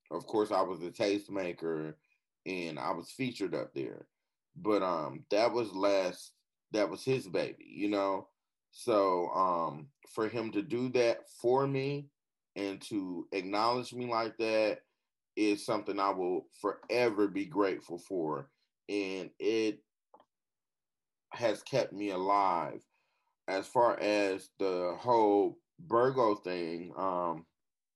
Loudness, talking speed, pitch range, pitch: -33 LUFS, 130 wpm, 95-125 Hz, 105 Hz